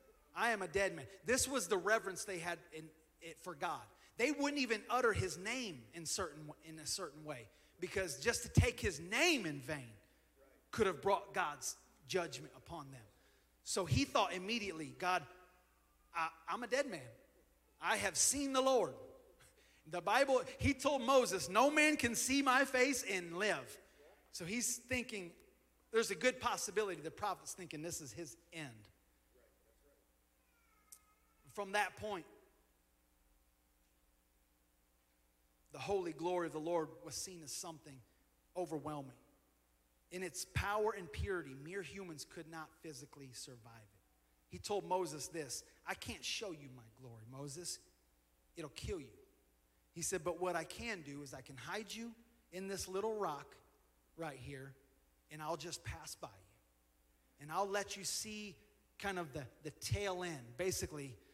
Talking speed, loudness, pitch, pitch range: 155 wpm, -39 LUFS, 170 Hz, 130-205 Hz